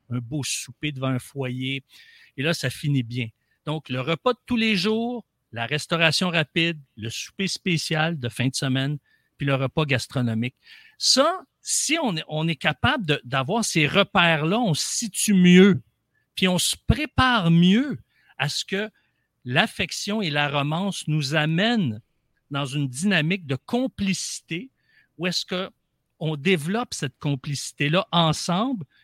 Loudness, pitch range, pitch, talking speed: -23 LUFS, 135-195 Hz, 160 Hz, 150 wpm